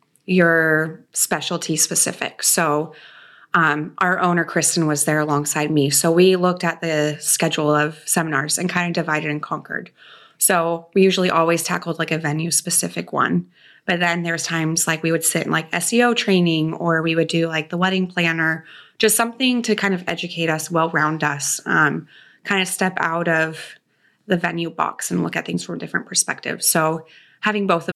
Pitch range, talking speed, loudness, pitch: 155-180 Hz, 185 wpm, -19 LUFS, 165 Hz